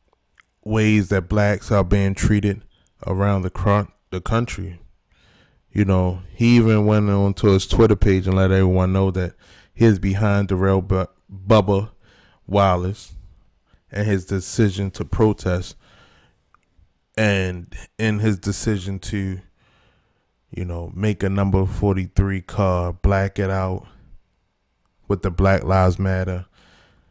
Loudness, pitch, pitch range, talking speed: -20 LUFS, 95 Hz, 95-105 Hz, 130 wpm